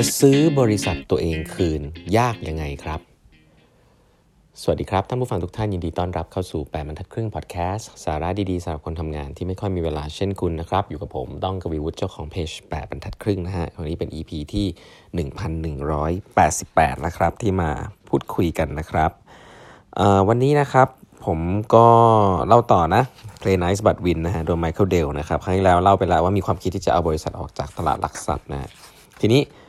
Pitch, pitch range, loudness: 90 Hz, 80-100 Hz, -21 LUFS